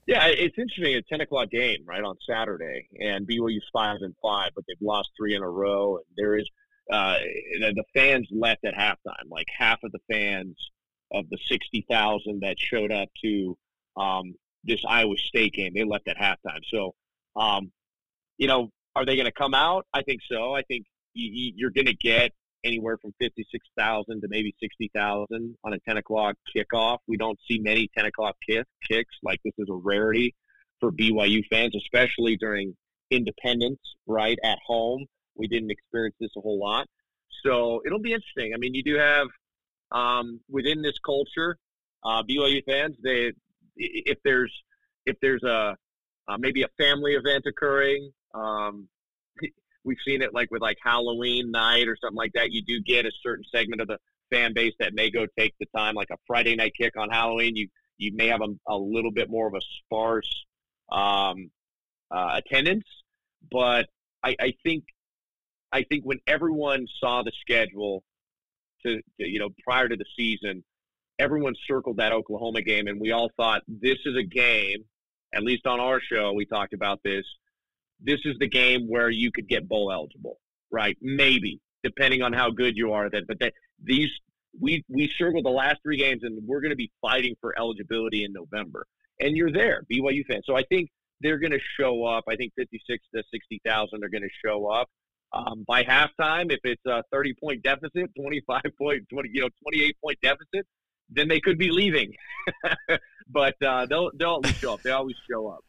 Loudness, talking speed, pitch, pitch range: -25 LUFS, 190 wpm, 120 Hz, 110-140 Hz